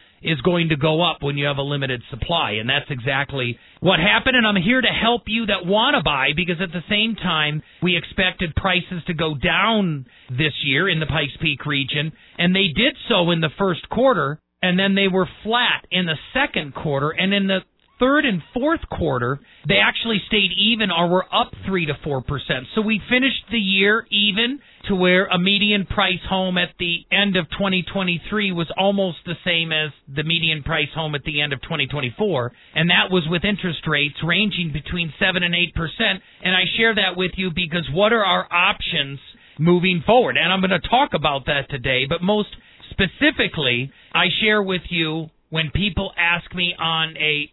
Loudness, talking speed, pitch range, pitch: -19 LUFS, 195 wpm, 155-200 Hz, 175 Hz